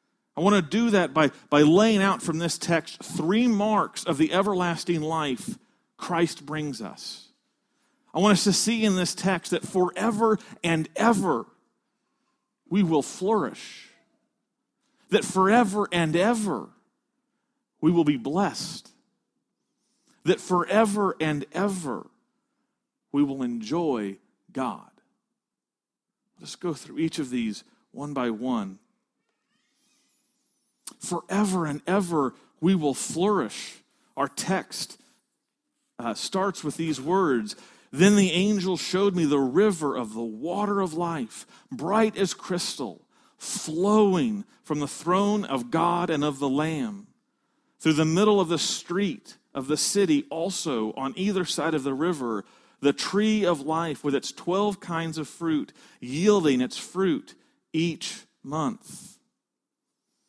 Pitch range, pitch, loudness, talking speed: 160-225 Hz, 190 Hz, -25 LUFS, 130 wpm